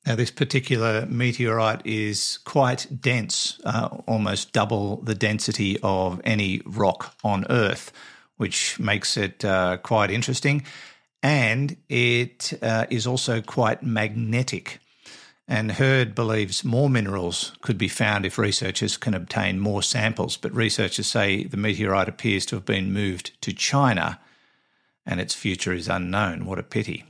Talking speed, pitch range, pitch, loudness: 140 wpm, 100-120 Hz, 110 Hz, -24 LUFS